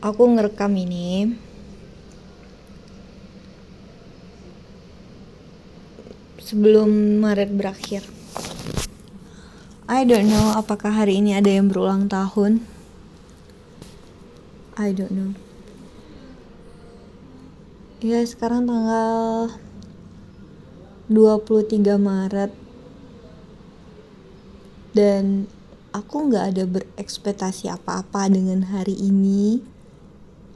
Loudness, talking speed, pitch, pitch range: -20 LUFS, 65 wpm, 205 Hz, 195-220 Hz